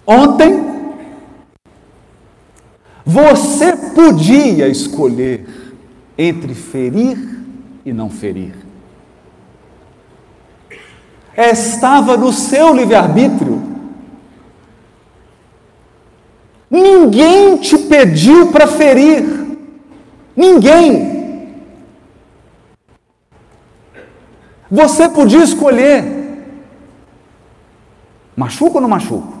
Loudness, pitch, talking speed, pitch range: -9 LUFS, 275 Hz, 55 wpm, 225-300 Hz